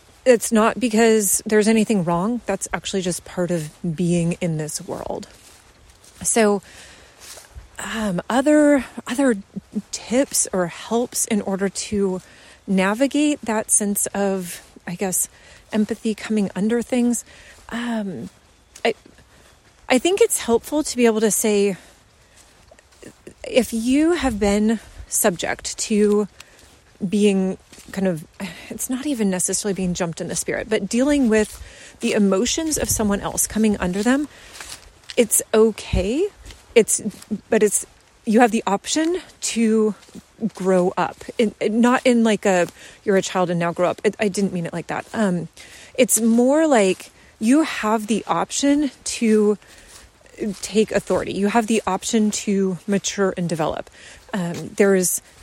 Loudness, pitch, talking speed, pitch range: -20 LUFS, 215 Hz, 140 wpm, 190-235 Hz